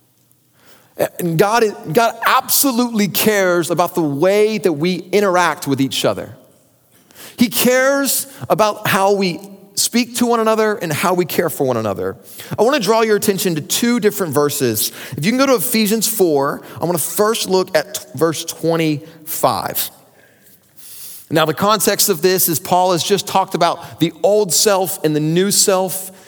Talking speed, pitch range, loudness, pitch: 170 wpm, 160-210 Hz, -16 LUFS, 185 Hz